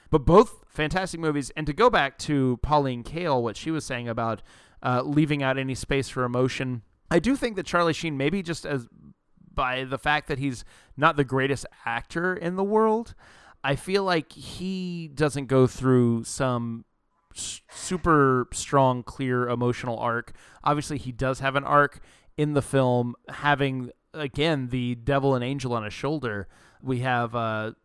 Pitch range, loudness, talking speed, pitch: 120-155 Hz, -25 LUFS, 170 wpm, 135 Hz